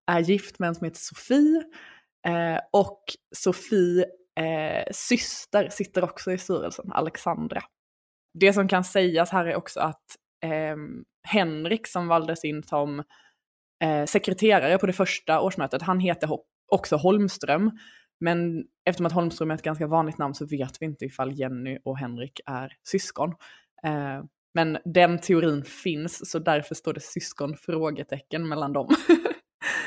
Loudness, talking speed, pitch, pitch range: -26 LUFS, 145 wpm, 170 Hz, 150-190 Hz